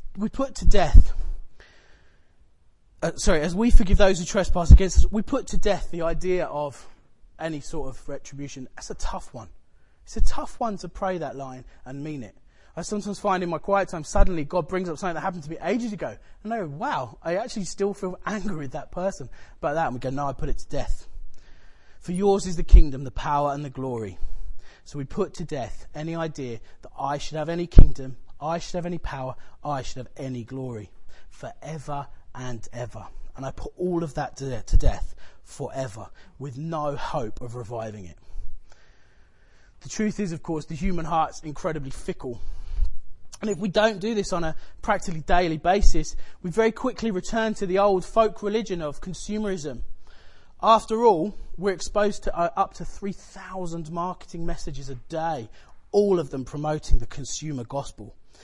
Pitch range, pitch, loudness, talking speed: 130-190 Hz, 155 Hz, -27 LUFS, 190 wpm